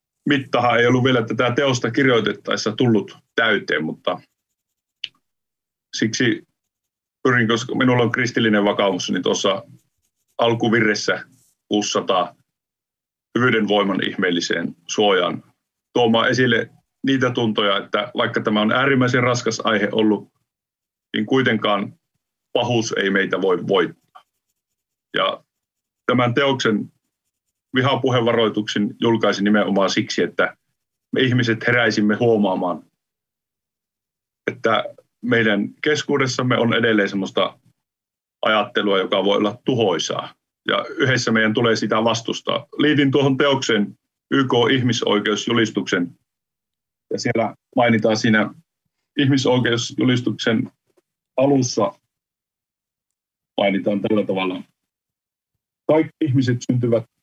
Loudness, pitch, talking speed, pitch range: -19 LUFS, 115 Hz, 95 wpm, 110-130 Hz